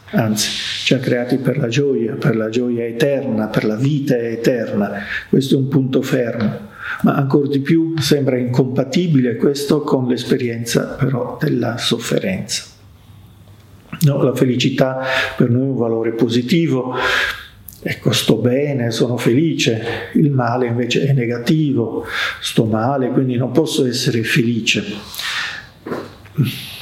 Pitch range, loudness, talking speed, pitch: 115-140 Hz, -17 LUFS, 130 wpm, 125 Hz